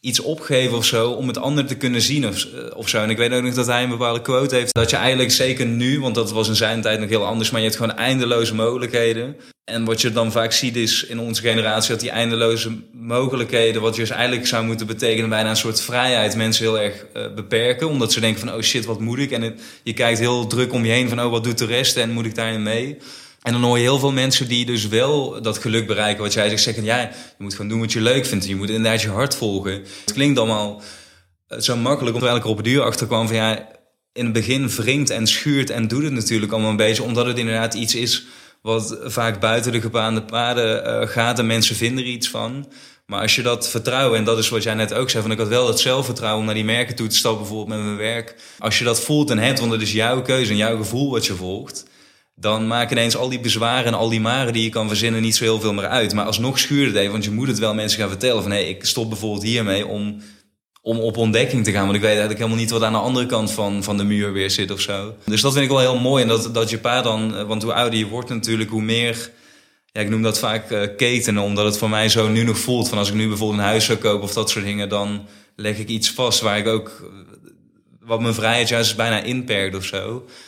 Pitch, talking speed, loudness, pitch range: 115 Hz, 270 wpm, -19 LUFS, 110-120 Hz